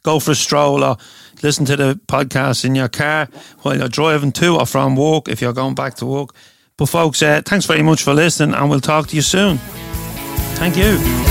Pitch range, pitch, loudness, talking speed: 135-155 Hz, 145 Hz, -15 LUFS, 220 wpm